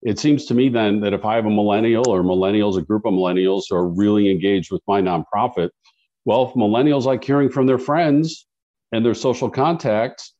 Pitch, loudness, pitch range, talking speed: 110 Hz, -18 LUFS, 100-130 Hz, 210 wpm